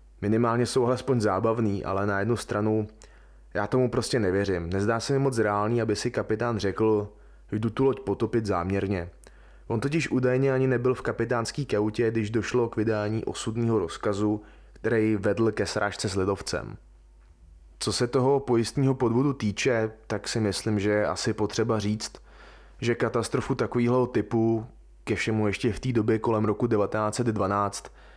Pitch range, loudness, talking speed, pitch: 100-120 Hz, -26 LUFS, 155 wpm, 110 Hz